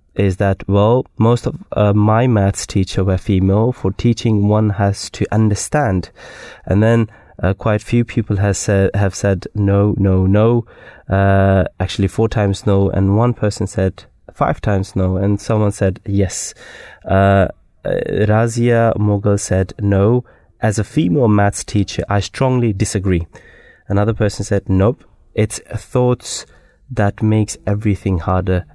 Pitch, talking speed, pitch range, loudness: 100 Hz, 150 wpm, 95-110 Hz, -16 LUFS